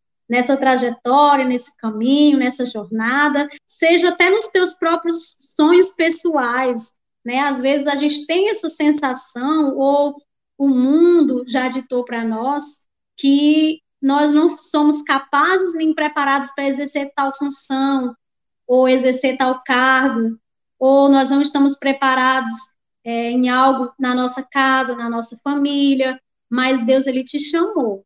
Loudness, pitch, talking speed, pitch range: -17 LUFS, 275 Hz, 135 wpm, 255-295 Hz